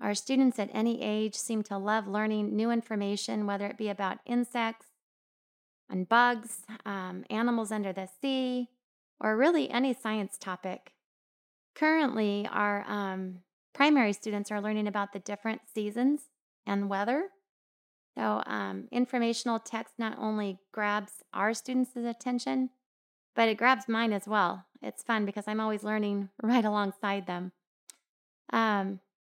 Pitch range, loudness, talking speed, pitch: 205-240 Hz, -31 LUFS, 135 wpm, 215 Hz